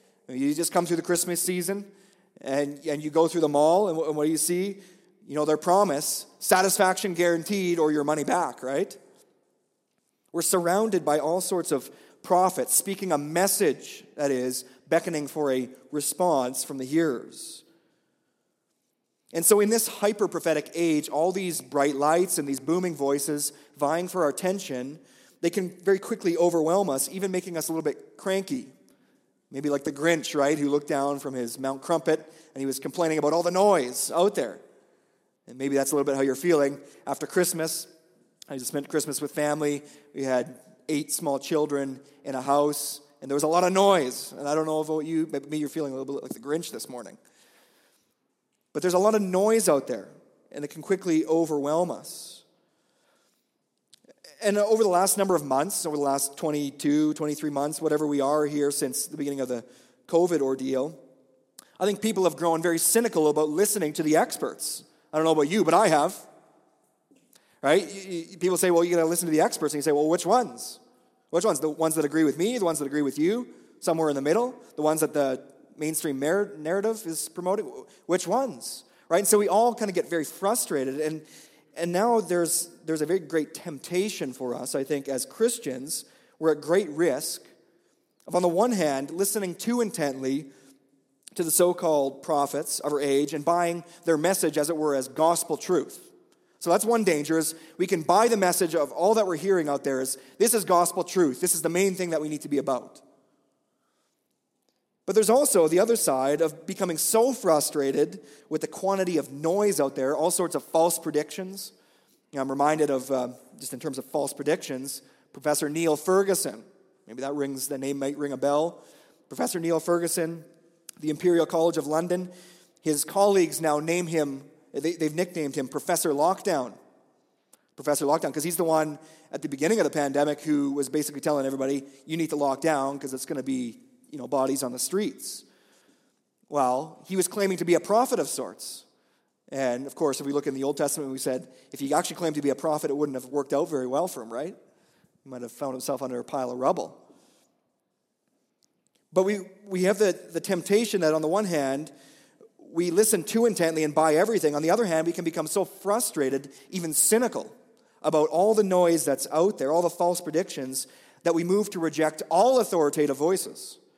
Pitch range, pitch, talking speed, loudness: 145-180 Hz, 160 Hz, 195 wpm, -26 LUFS